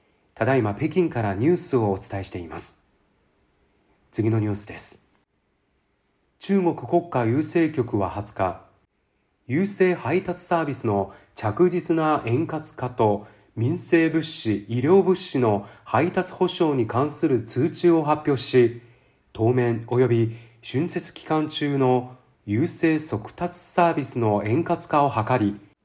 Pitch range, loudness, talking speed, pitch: 110-165 Hz, -23 LUFS, 235 characters per minute, 125 Hz